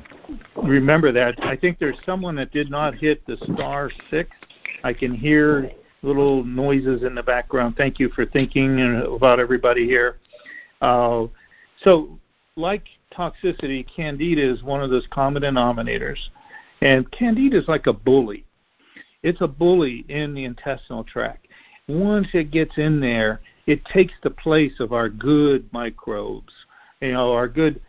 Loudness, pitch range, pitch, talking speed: -20 LUFS, 125-155 Hz, 140 Hz, 150 wpm